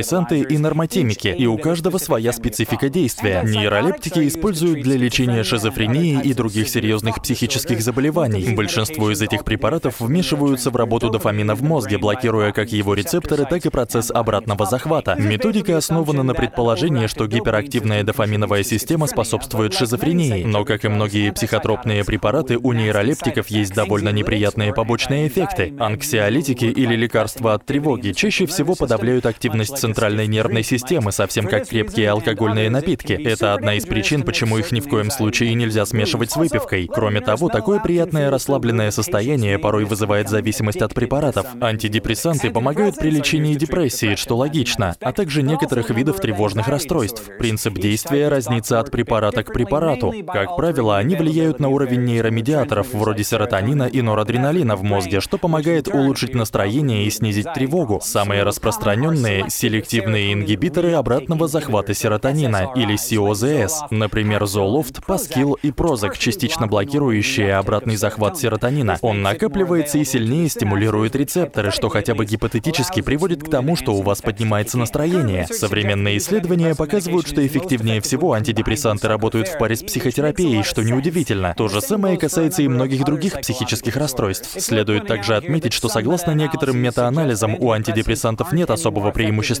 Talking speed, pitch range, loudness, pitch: 145 wpm, 105-145 Hz, -19 LUFS, 115 Hz